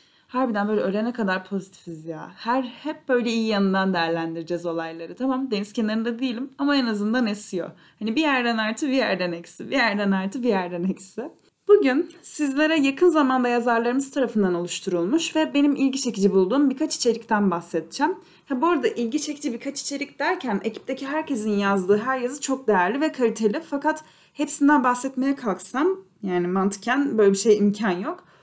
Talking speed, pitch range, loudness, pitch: 165 wpm, 200-280 Hz, -23 LUFS, 235 Hz